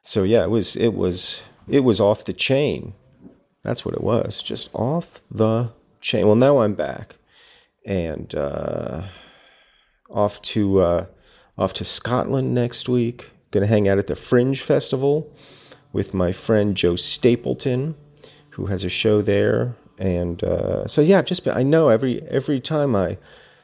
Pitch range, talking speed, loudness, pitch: 100-135 Hz, 160 wpm, -20 LUFS, 115 Hz